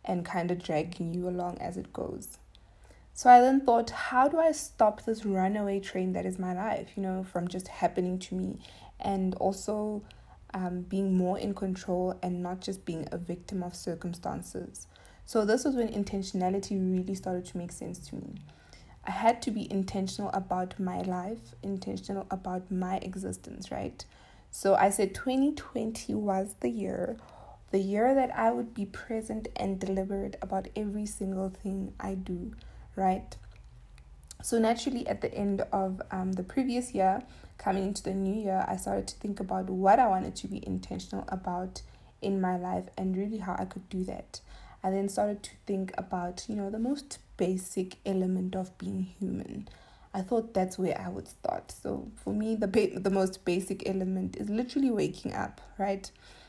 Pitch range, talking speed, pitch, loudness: 185-210 Hz, 175 wpm, 195 Hz, -31 LUFS